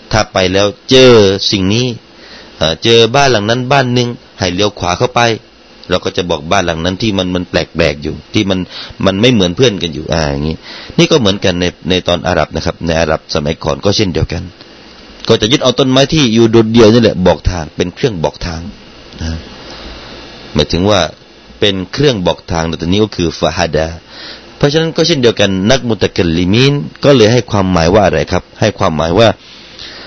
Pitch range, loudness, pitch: 85-115 Hz, -11 LUFS, 100 Hz